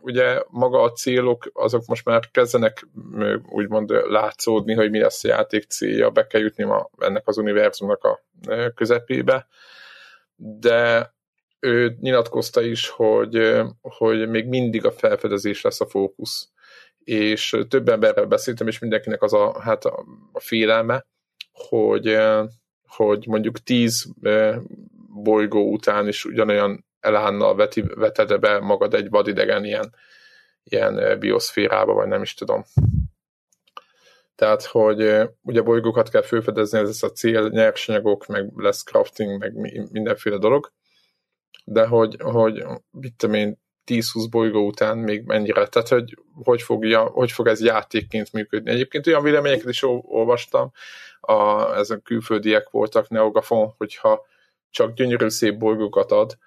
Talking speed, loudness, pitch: 130 wpm, -20 LUFS, 120 Hz